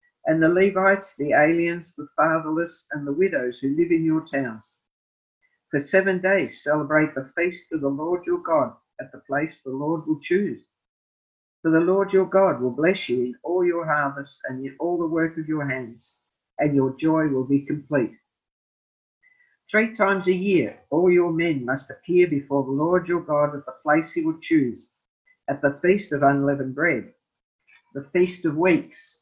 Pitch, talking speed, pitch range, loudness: 160 Hz, 185 wpm, 140-185 Hz, -23 LUFS